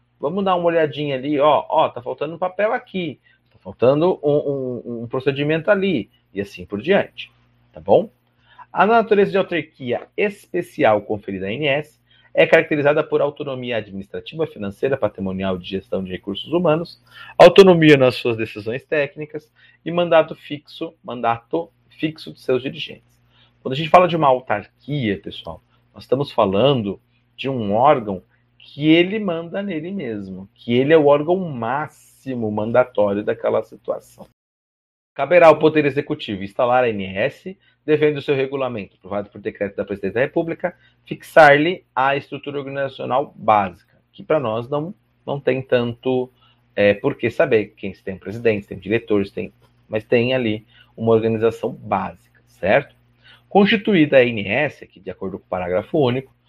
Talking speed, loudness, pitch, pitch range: 150 wpm, -19 LUFS, 125 Hz, 110-155 Hz